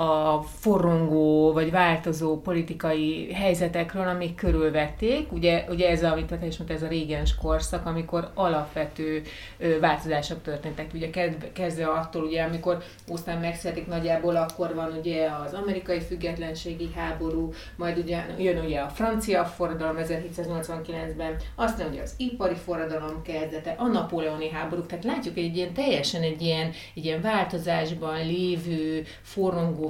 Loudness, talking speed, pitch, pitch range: -27 LUFS, 130 wpm, 165 Hz, 160-175 Hz